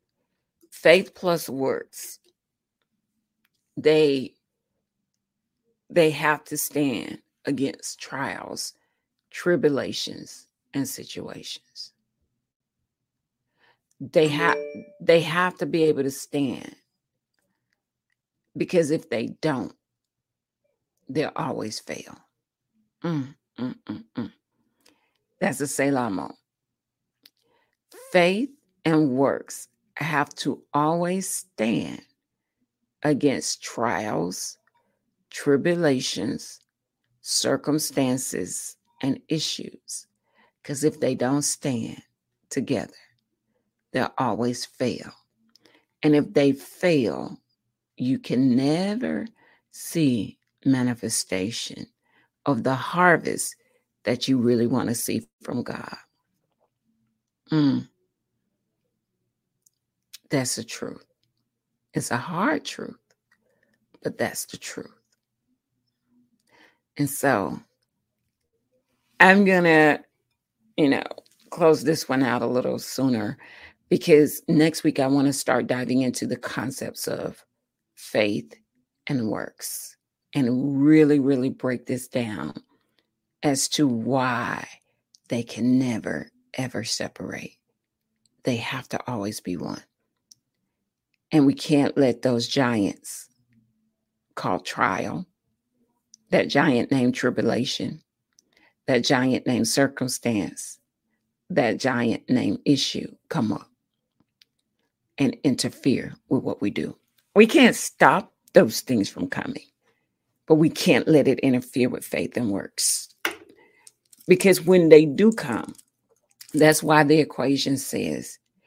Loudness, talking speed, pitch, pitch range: -23 LUFS, 100 wpm, 140 Hz, 125-165 Hz